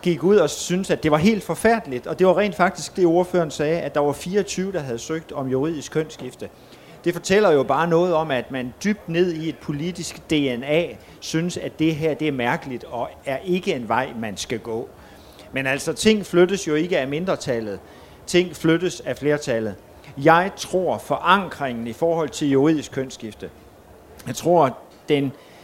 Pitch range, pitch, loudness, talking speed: 135-180 Hz, 160 Hz, -22 LUFS, 185 wpm